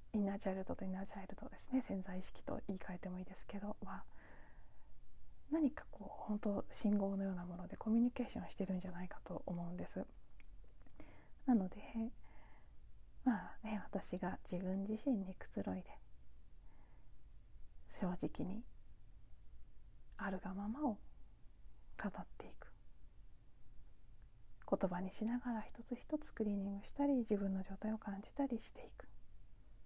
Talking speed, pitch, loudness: 310 characters per minute, 195 Hz, -43 LUFS